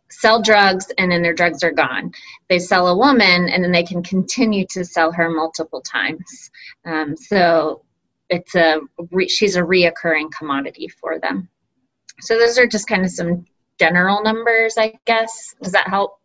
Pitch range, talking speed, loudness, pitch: 165-210 Hz, 175 wpm, -17 LUFS, 180 Hz